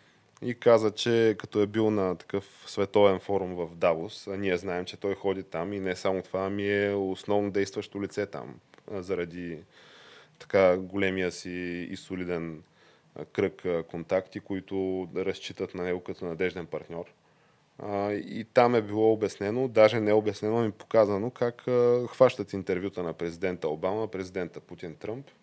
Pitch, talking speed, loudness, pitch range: 100 Hz, 150 wpm, -28 LUFS, 90-105 Hz